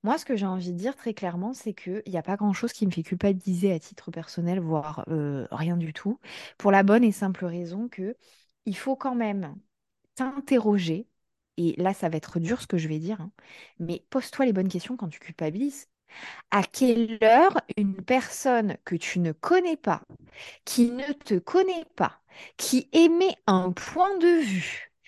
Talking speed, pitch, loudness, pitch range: 190 wpm, 200 Hz, -26 LUFS, 175-250 Hz